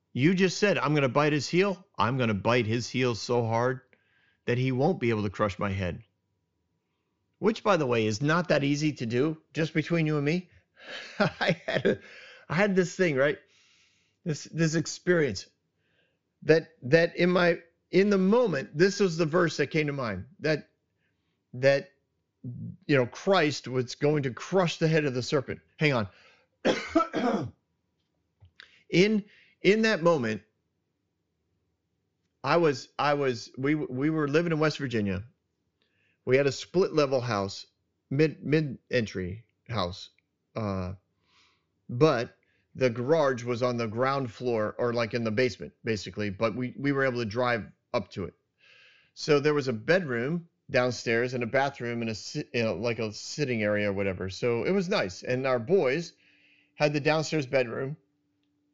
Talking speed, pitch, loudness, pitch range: 160 wpm, 130 Hz, -27 LUFS, 105-155 Hz